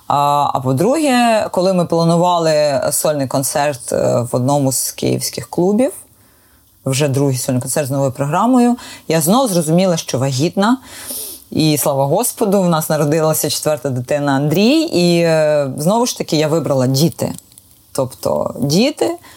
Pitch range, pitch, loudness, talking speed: 140-190 Hz, 155 Hz, -15 LUFS, 130 wpm